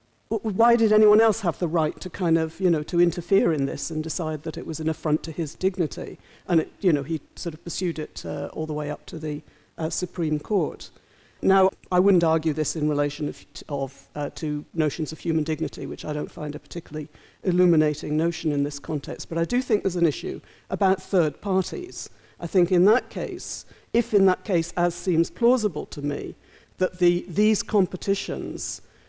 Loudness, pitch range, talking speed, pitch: -24 LUFS, 155-185 Hz, 205 wpm, 165 Hz